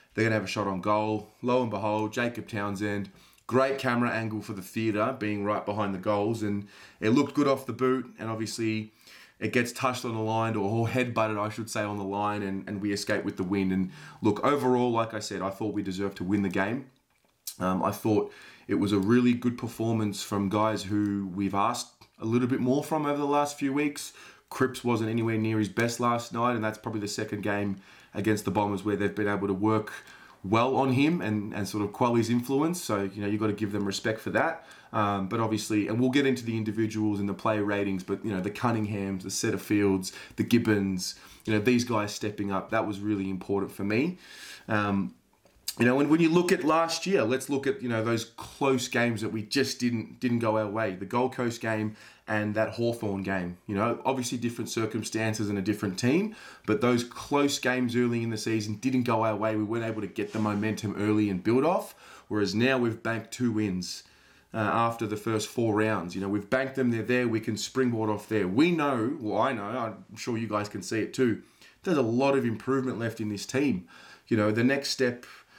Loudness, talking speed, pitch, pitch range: -28 LUFS, 230 wpm, 110 Hz, 105-120 Hz